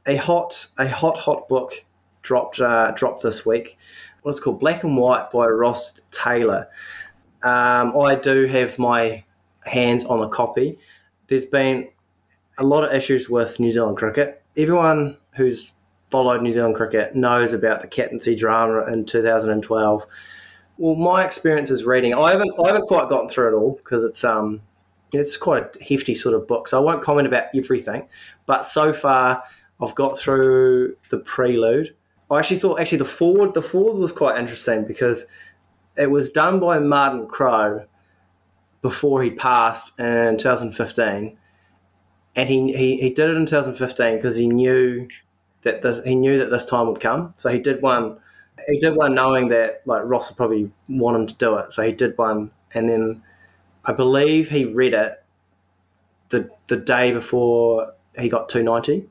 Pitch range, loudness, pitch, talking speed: 115-140 Hz, -19 LUFS, 125 Hz, 170 wpm